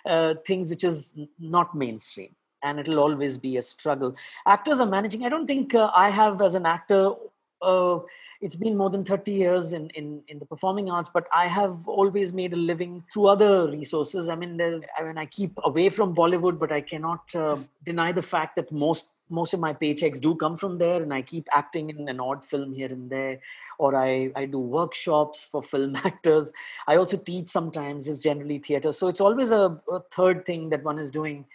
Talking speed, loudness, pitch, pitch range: 210 wpm, -25 LUFS, 165 Hz, 150-185 Hz